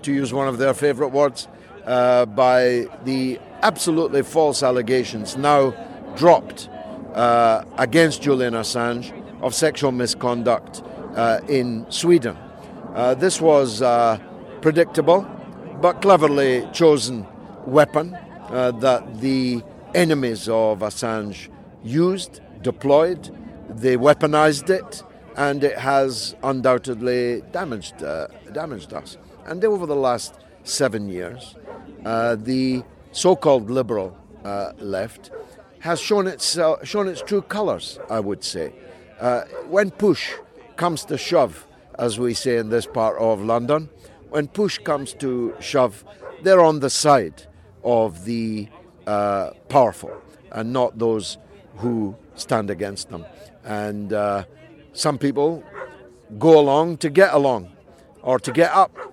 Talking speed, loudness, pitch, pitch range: 125 wpm, -20 LUFS, 130 Hz, 115-155 Hz